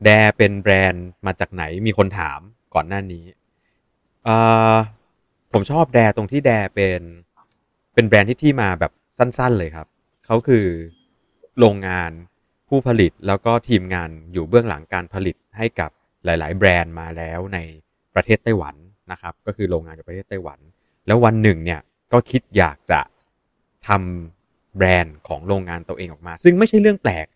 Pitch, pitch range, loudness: 95 Hz, 85-110 Hz, -18 LUFS